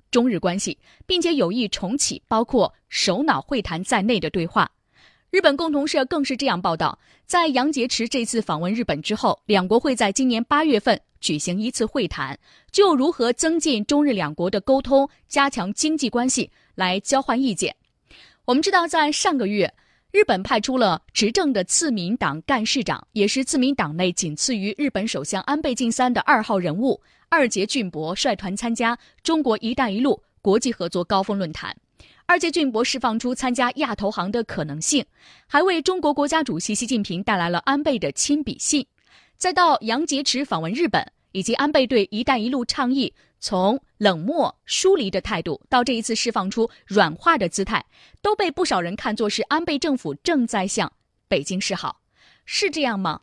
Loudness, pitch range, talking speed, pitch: -21 LUFS, 200-285 Hz, 280 characters per minute, 240 Hz